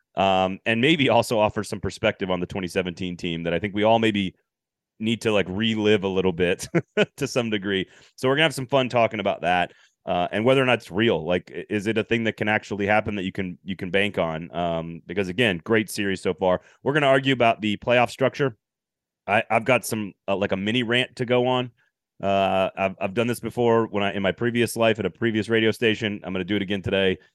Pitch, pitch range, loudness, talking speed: 105 Hz, 95-115 Hz, -23 LUFS, 240 wpm